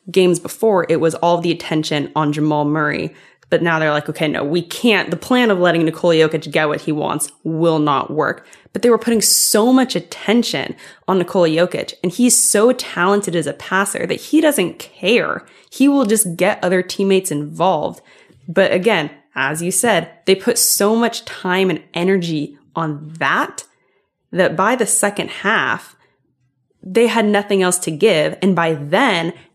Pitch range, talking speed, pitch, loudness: 155-210 Hz, 175 wpm, 175 Hz, -16 LUFS